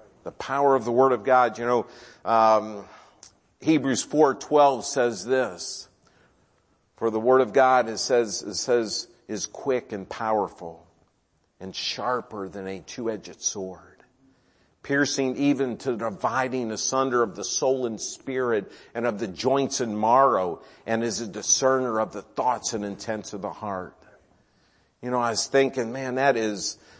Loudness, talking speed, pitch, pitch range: -24 LUFS, 155 wpm, 120 Hz, 105-130 Hz